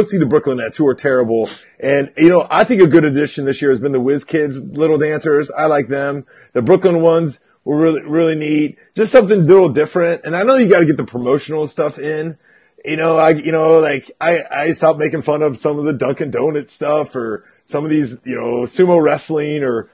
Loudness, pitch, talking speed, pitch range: -15 LUFS, 150 Hz, 230 wpm, 140-160 Hz